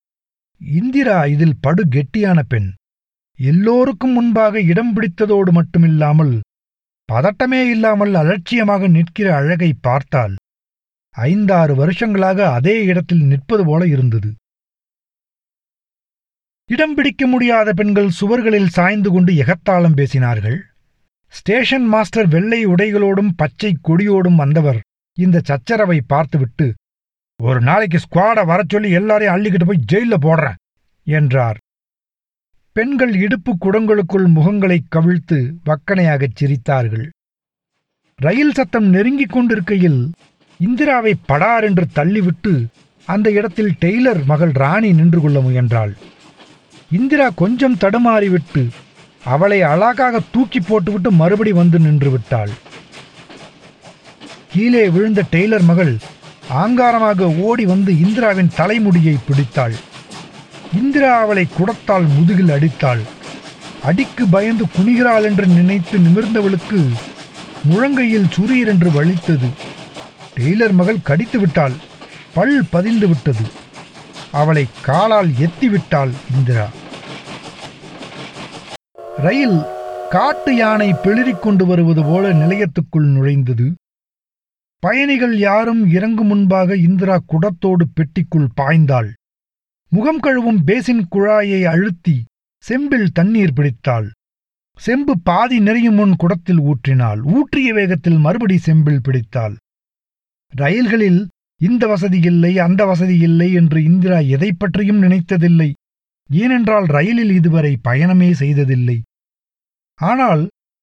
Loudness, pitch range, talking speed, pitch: -14 LUFS, 150-210 Hz, 95 wpm, 180 Hz